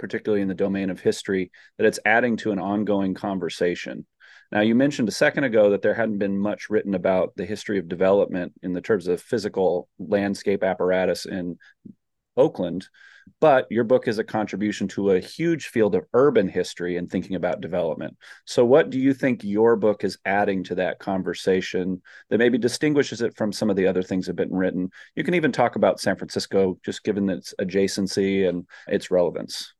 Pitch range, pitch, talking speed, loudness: 95-105 Hz, 100 Hz, 195 wpm, -23 LUFS